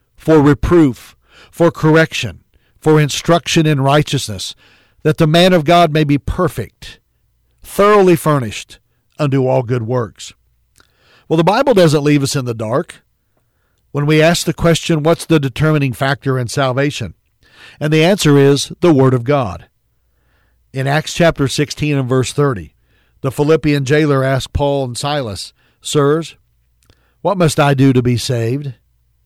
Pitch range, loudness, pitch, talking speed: 120-155 Hz, -14 LUFS, 140 Hz, 150 wpm